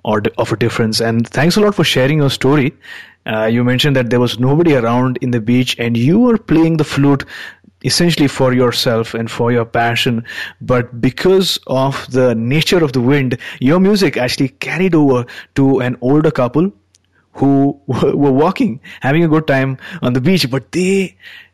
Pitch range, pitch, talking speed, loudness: 120-150 Hz, 130 Hz, 180 wpm, -14 LUFS